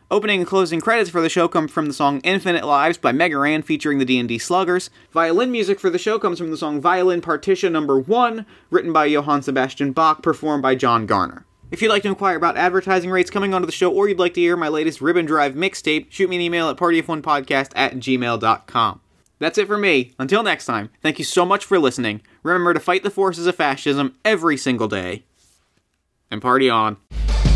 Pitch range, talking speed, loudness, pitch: 135-185 Hz, 215 wpm, -19 LUFS, 165 Hz